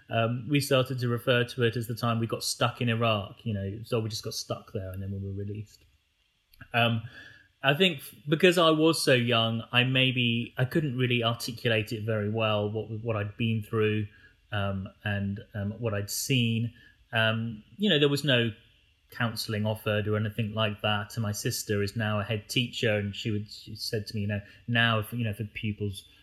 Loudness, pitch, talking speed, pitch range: -28 LUFS, 115 Hz, 205 wpm, 105-120 Hz